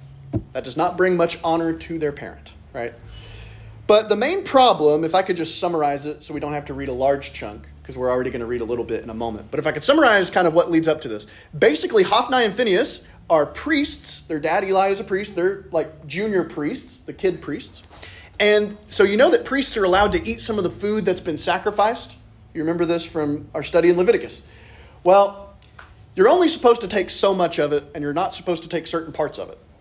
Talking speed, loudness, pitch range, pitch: 235 wpm, -20 LUFS, 135-195 Hz, 165 Hz